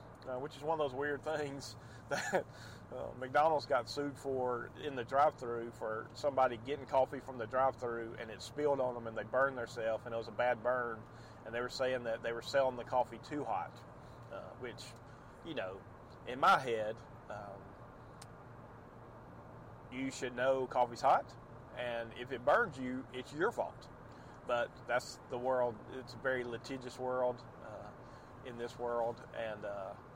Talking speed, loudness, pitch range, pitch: 175 wpm, -37 LUFS, 120-130 Hz, 125 Hz